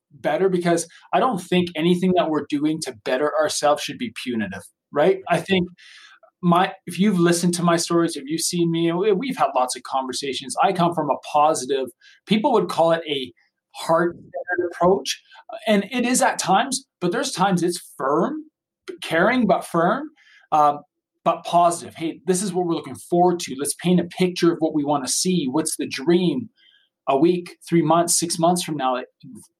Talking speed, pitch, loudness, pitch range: 190 wpm, 175 Hz, -21 LUFS, 160-190 Hz